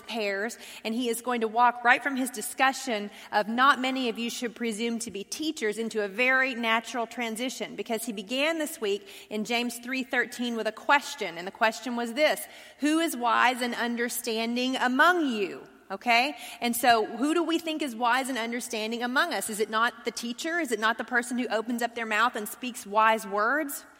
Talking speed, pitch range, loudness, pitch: 205 wpm, 225-260 Hz, -27 LUFS, 235 Hz